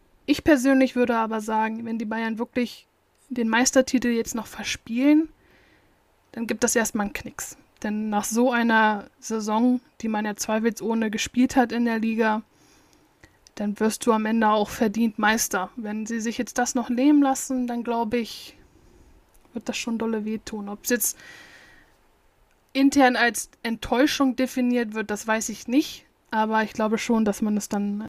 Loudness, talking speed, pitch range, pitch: -24 LUFS, 170 wpm, 220-250 Hz, 230 Hz